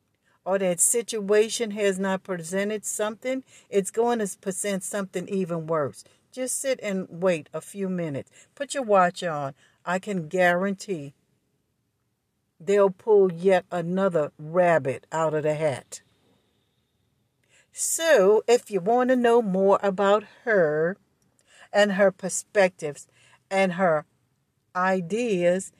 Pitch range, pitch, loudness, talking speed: 165-205 Hz, 190 Hz, -24 LUFS, 120 wpm